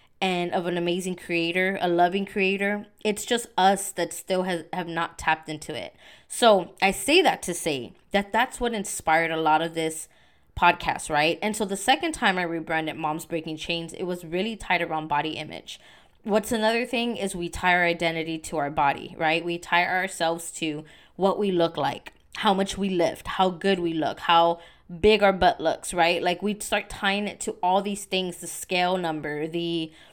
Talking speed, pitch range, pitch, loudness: 195 wpm, 165-195 Hz, 180 Hz, -25 LUFS